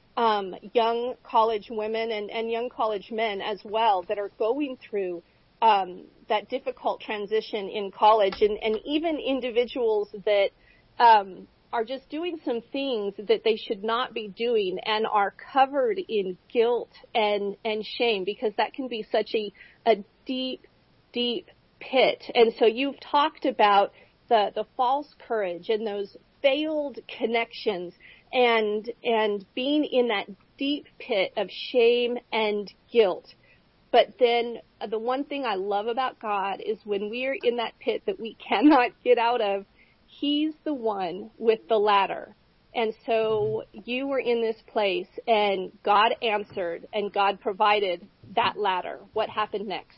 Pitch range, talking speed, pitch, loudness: 210-255 Hz, 150 wpm, 225 Hz, -26 LUFS